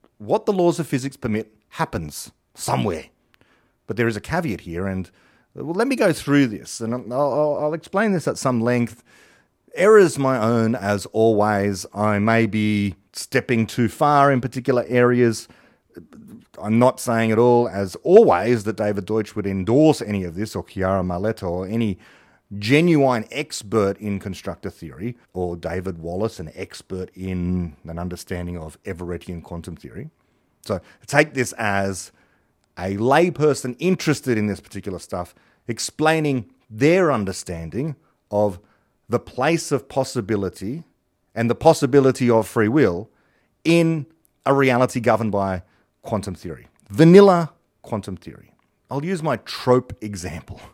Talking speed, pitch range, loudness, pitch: 145 wpm, 95-135 Hz, -20 LUFS, 110 Hz